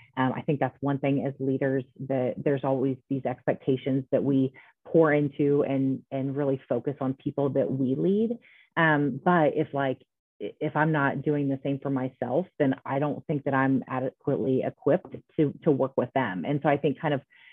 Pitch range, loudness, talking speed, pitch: 135-145 Hz, -27 LUFS, 195 wpm, 140 Hz